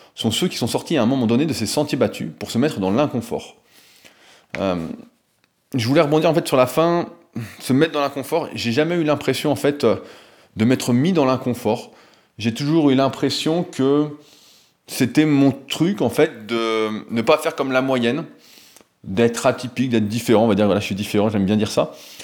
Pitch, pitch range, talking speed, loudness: 130 Hz, 115-150 Hz, 200 wpm, -20 LUFS